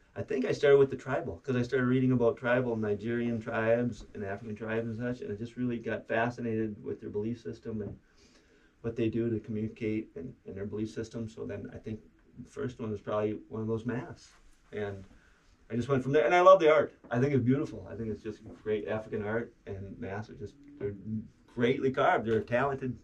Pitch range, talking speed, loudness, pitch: 105-125 Hz, 220 wpm, -31 LUFS, 115 Hz